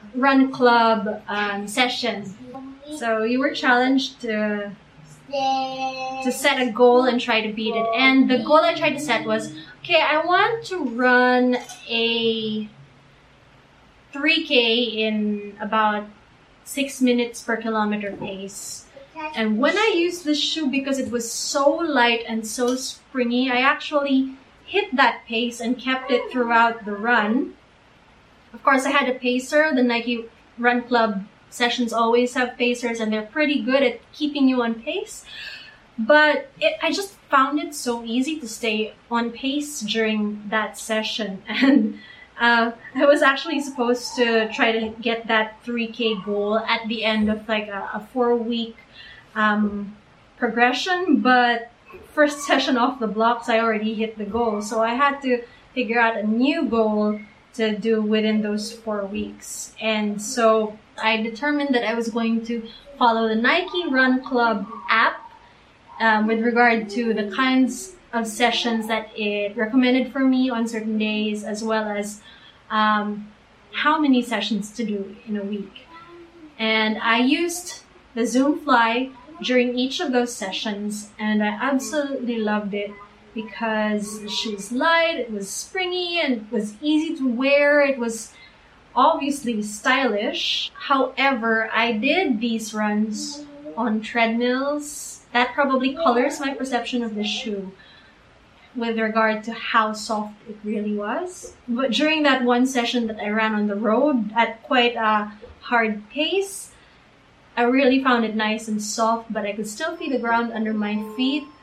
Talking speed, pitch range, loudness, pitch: 155 wpm, 220-265 Hz, -21 LUFS, 235 Hz